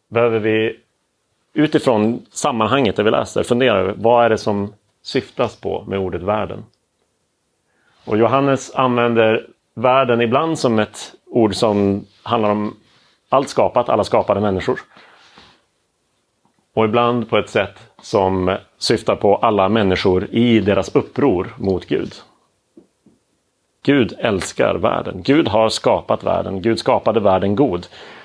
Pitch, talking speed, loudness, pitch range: 110 Hz, 125 wpm, -17 LUFS, 100-120 Hz